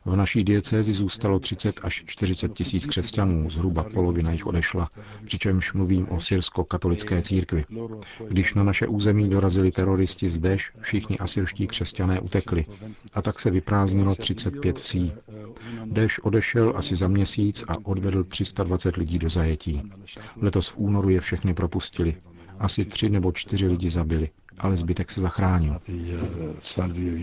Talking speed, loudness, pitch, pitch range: 140 wpm, -24 LUFS, 95 Hz, 90-105 Hz